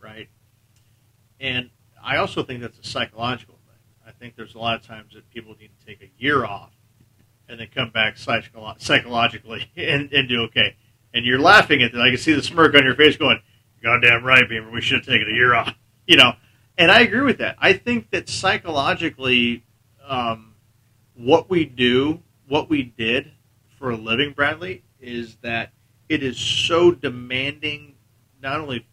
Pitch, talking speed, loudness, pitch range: 120 Hz, 185 wpm, -18 LUFS, 115-135 Hz